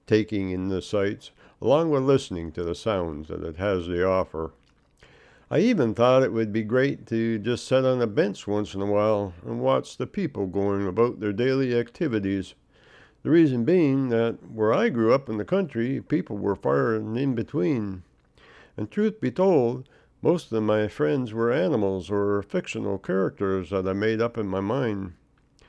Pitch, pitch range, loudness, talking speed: 110 Hz, 100-130 Hz, -25 LUFS, 180 wpm